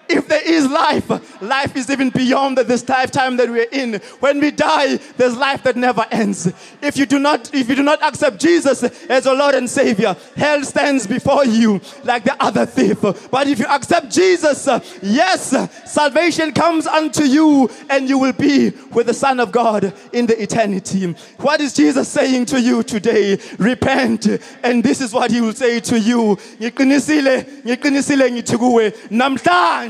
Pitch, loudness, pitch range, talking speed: 265 Hz, -16 LUFS, 235-285 Hz, 170 wpm